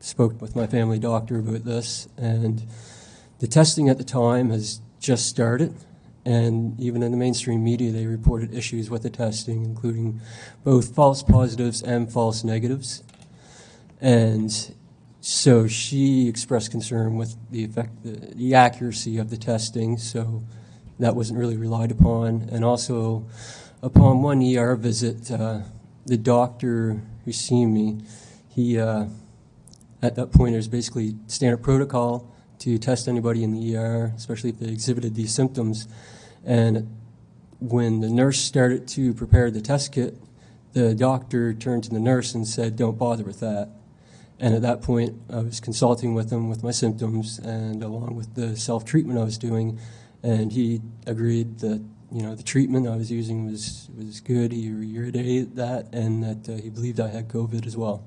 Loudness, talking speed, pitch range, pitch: -23 LUFS, 160 wpm, 110-120 Hz, 115 Hz